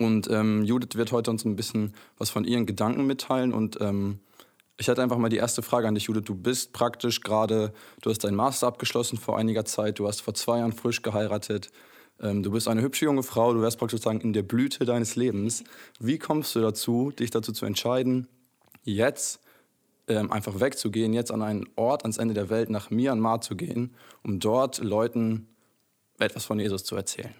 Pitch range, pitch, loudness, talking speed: 105-120 Hz, 115 Hz, -27 LUFS, 200 wpm